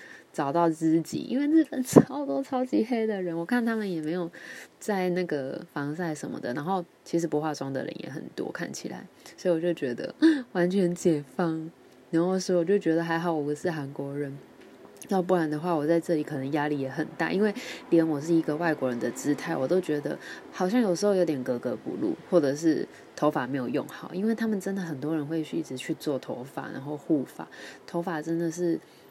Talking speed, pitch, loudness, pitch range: 310 characters per minute, 170 Hz, -28 LUFS, 150-190 Hz